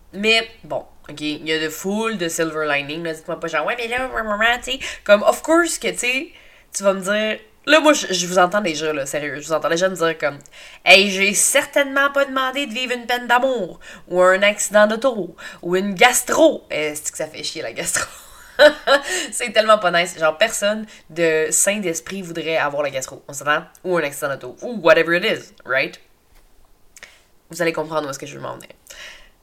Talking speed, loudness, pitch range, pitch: 210 wpm, -18 LUFS, 160-245 Hz, 190 Hz